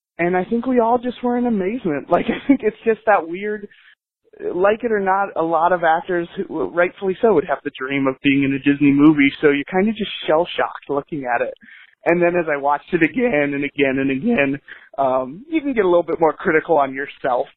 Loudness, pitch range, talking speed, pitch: -19 LUFS, 145-215 Hz, 235 wpm, 175 Hz